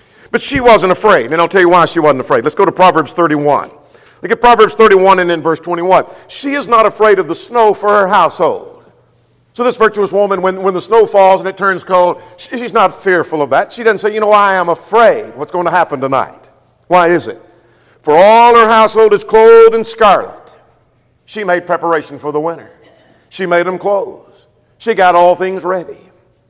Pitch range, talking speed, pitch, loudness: 175-220 Hz, 210 wpm, 190 Hz, -10 LUFS